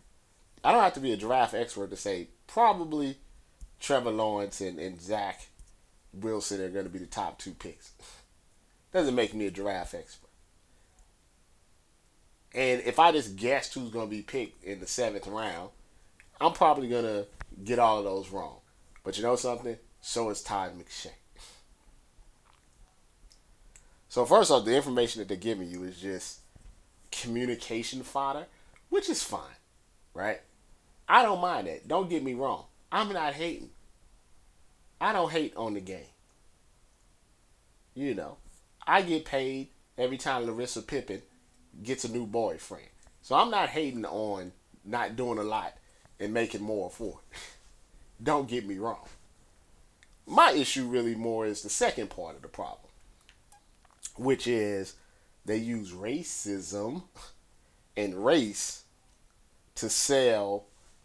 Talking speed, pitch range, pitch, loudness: 145 wpm, 100-125 Hz, 110 Hz, -30 LUFS